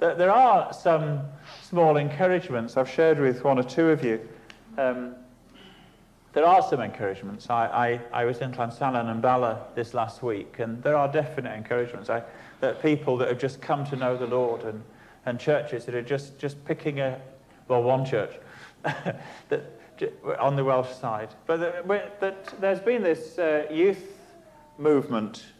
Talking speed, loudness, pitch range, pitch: 165 wpm, -26 LUFS, 120-160 Hz, 135 Hz